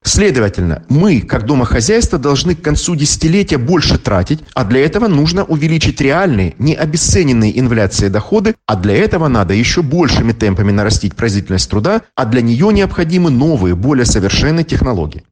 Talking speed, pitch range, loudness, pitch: 150 wpm, 105-165 Hz, -12 LUFS, 130 Hz